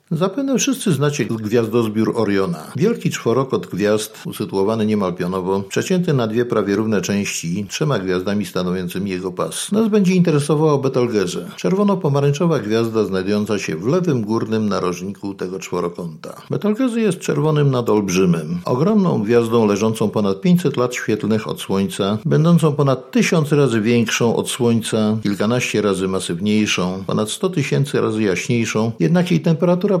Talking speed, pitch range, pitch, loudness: 135 wpm, 105-160 Hz, 120 Hz, -18 LUFS